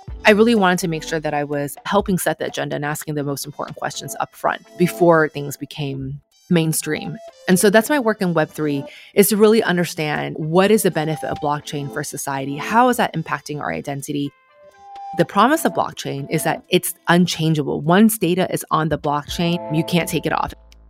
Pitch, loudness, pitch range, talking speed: 160 Hz, -19 LUFS, 145-185 Hz, 200 wpm